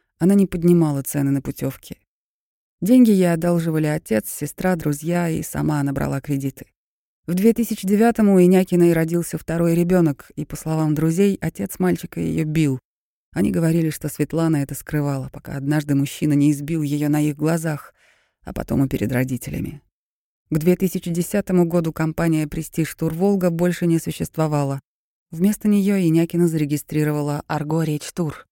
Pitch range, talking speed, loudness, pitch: 150-175 Hz, 145 wpm, -20 LUFS, 160 Hz